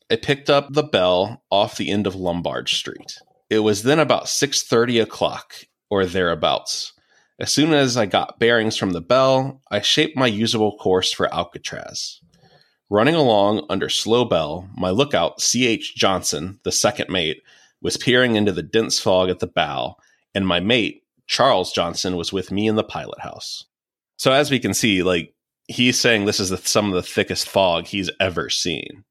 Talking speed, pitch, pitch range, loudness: 180 wpm, 110 Hz, 95-130 Hz, -19 LUFS